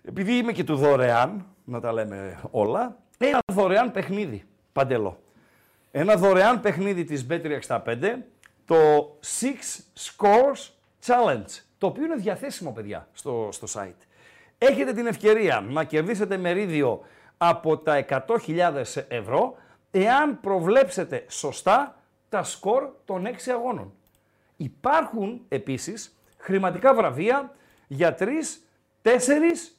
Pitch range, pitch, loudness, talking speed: 160-250 Hz, 200 Hz, -24 LUFS, 115 wpm